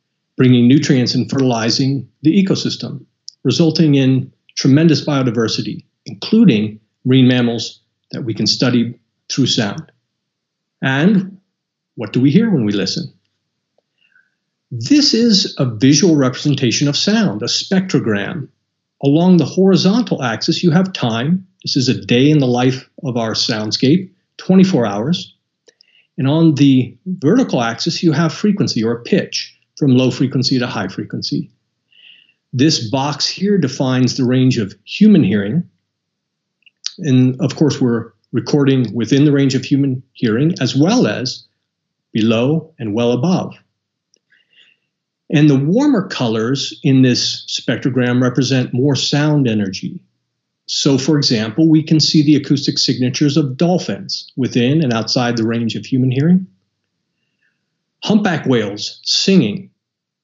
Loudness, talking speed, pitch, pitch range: -15 LUFS, 130 wpm, 135 Hz, 120-160 Hz